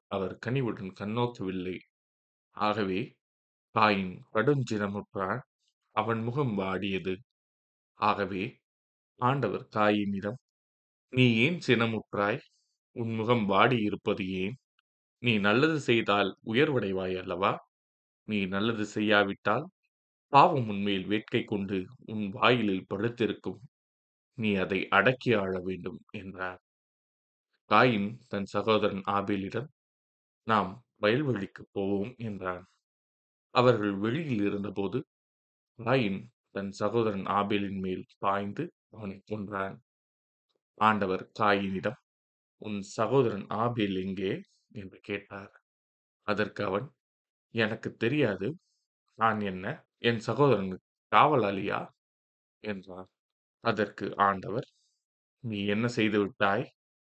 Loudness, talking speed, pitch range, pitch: -29 LUFS, 85 wpm, 95-110 Hz, 100 Hz